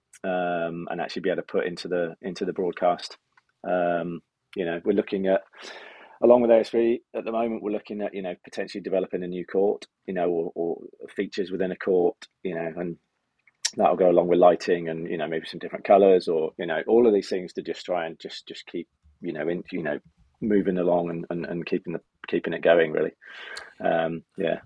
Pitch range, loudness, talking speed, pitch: 85-105 Hz, -25 LUFS, 215 wpm, 90 Hz